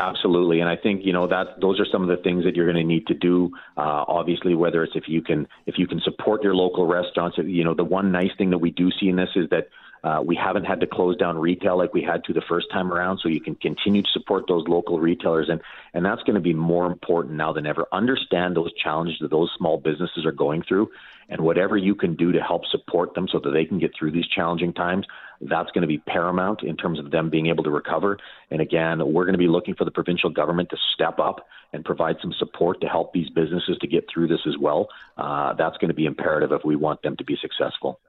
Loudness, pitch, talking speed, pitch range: -23 LUFS, 85 Hz, 260 wpm, 85-90 Hz